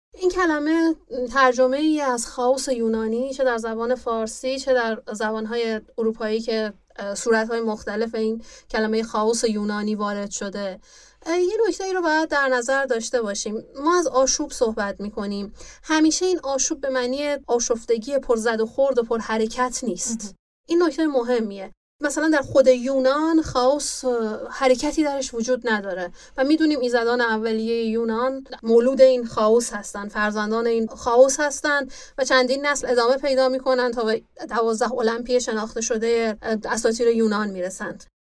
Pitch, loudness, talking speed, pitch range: 240 Hz, -22 LUFS, 150 wpm, 225-270 Hz